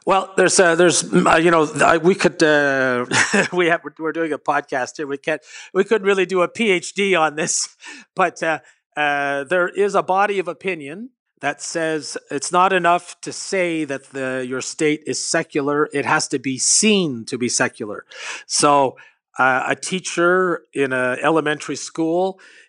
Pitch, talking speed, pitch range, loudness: 160 Hz, 175 wpm, 145-180 Hz, -18 LUFS